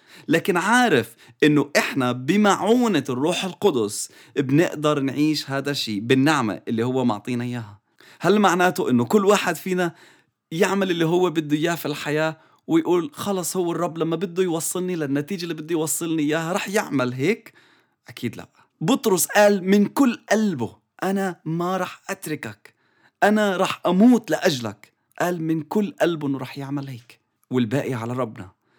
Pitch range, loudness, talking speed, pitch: 135-190 Hz, -22 LUFS, 145 wpm, 160 Hz